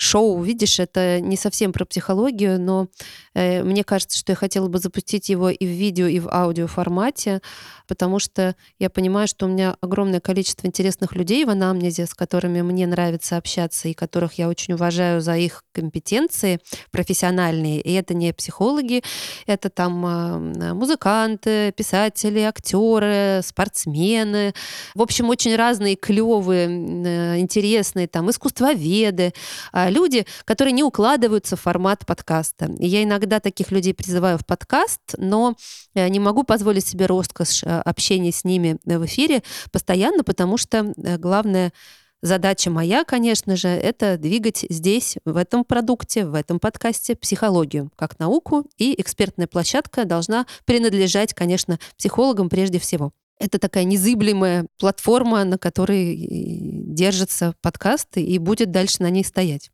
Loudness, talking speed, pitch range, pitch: -20 LUFS, 140 wpm, 175-215 Hz, 190 Hz